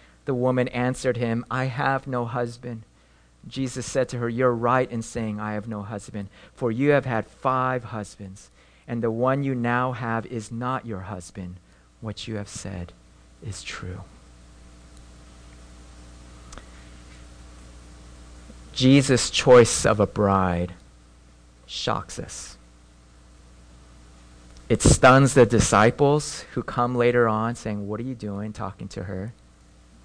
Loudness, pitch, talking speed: -23 LUFS, 100 Hz, 130 wpm